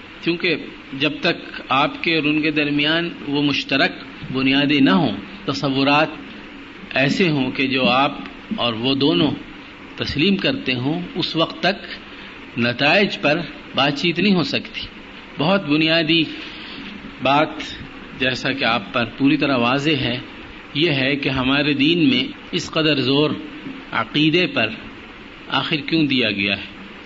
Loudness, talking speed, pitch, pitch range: -19 LUFS, 140 wpm, 145 Hz, 135-165 Hz